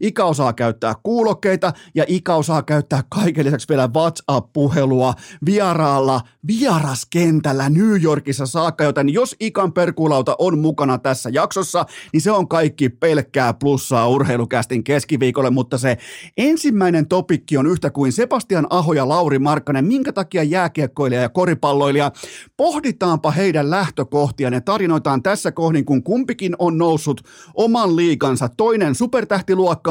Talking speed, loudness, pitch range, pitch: 130 wpm, -18 LUFS, 140-185 Hz, 155 Hz